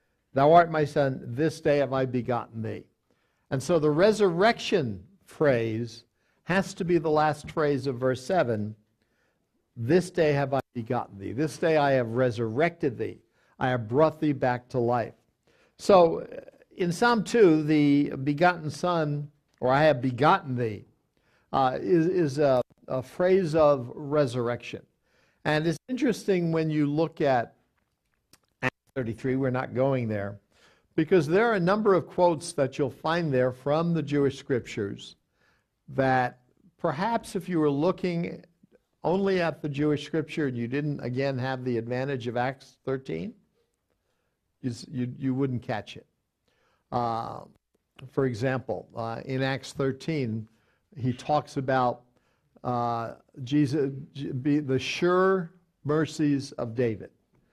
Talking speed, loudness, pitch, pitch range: 140 wpm, -27 LUFS, 145 Hz, 125-160 Hz